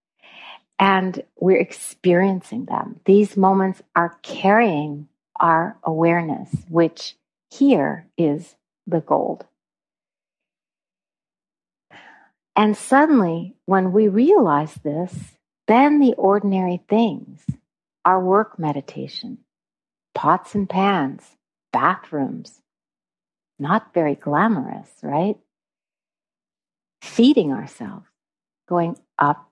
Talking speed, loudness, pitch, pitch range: 80 wpm, -19 LUFS, 190 Hz, 170-210 Hz